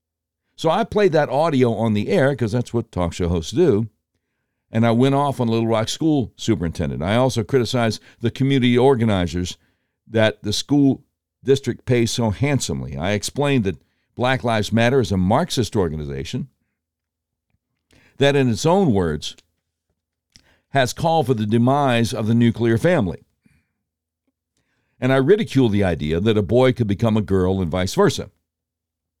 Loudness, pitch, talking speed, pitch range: -19 LUFS, 115 Hz, 155 wpm, 90-130 Hz